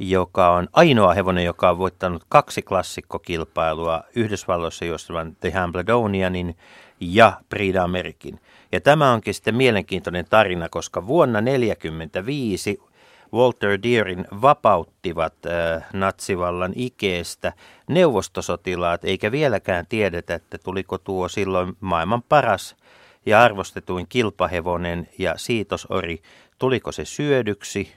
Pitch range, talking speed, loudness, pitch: 85-100 Hz, 105 wpm, -21 LUFS, 90 Hz